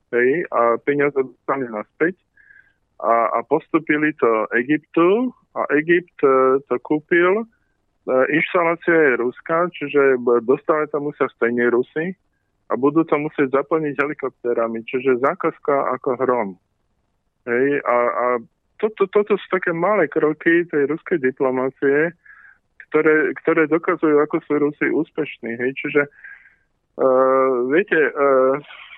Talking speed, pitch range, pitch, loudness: 125 wpm, 130-165 Hz, 145 Hz, -19 LUFS